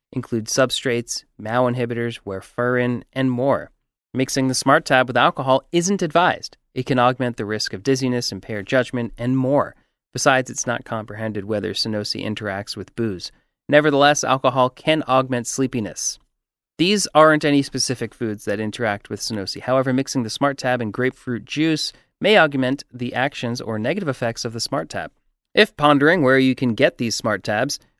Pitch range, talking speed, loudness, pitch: 115-135 Hz, 165 wpm, -20 LUFS, 125 Hz